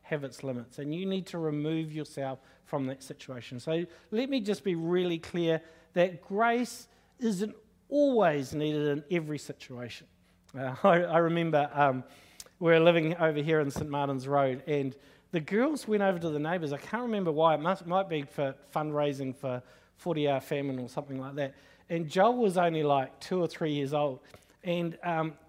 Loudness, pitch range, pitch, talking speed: -30 LUFS, 140-175 Hz, 155 Hz, 185 wpm